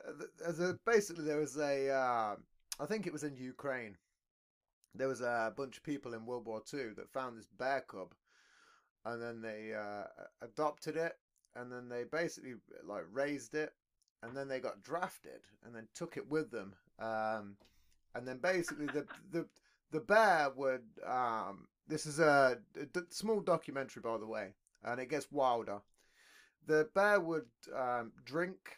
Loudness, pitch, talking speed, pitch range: -38 LUFS, 140 Hz, 165 wpm, 120-155 Hz